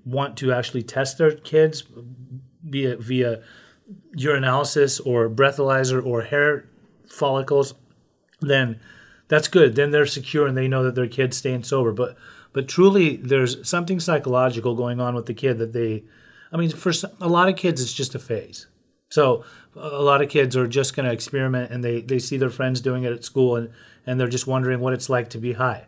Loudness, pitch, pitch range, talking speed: -22 LUFS, 130 Hz, 125-145 Hz, 190 wpm